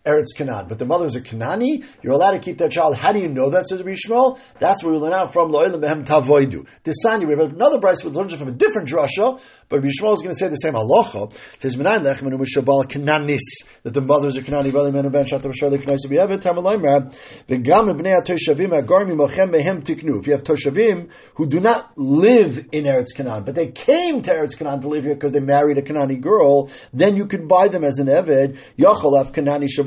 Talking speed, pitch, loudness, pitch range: 190 wpm, 150 Hz, -18 LUFS, 140-190 Hz